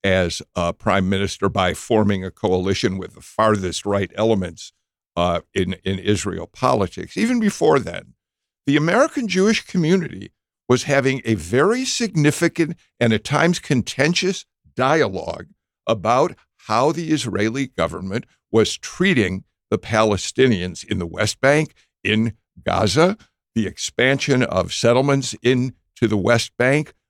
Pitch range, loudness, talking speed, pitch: 95-140 Hz, -20 LUFS, 130 wpm, 115 Hz